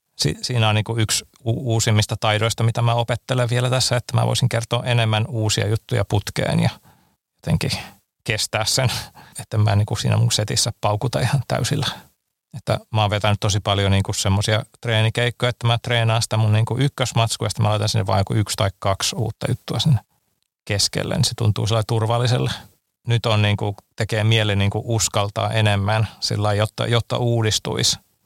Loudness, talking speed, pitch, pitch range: -20 LUFS, 175 wpm, 110 Hz, 105-120 Hz